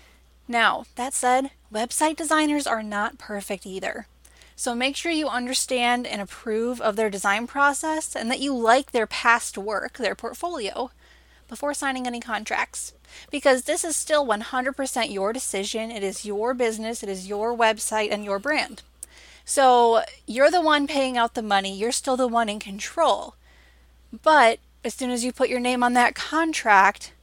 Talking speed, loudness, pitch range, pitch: 170 wpm, -23 LUFS, 215-275 Hz, 245 Hz